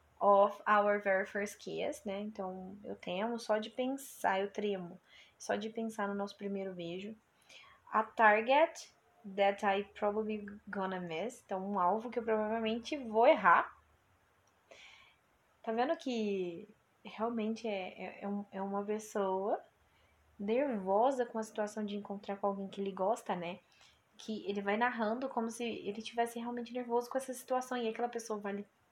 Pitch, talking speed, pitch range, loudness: 210 Hz, 155 wpm, 200-235 Hz, -35 LUFS